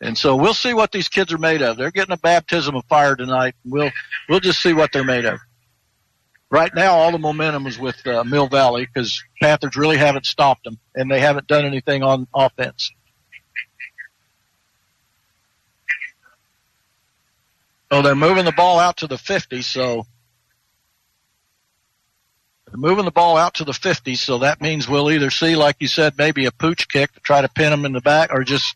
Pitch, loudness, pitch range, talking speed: 140 Hz, -17 LUFS, 130-160 Hz, 185 wpm